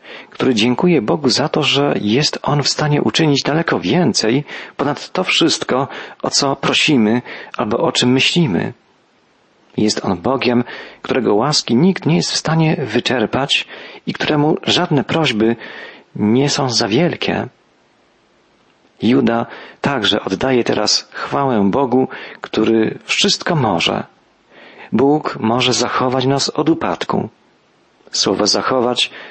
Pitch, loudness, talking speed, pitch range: 130 Hz, -16 LUFS, 120 wpm, 115-150 Hz